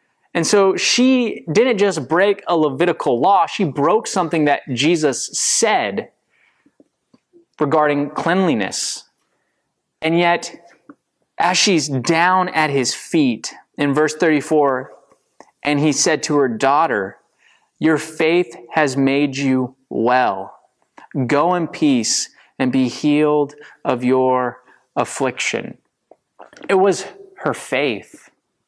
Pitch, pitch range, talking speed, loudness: 155 Hz, 140-180 Hz, 110 wpm, -17 LUFS